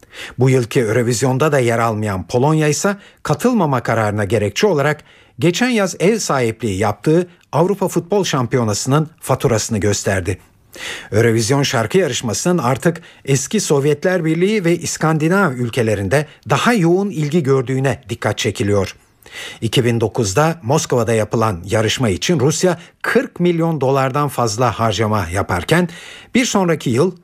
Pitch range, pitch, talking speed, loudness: 115-170 Hz, 135 Hz, 115 wpm, -17 LUFS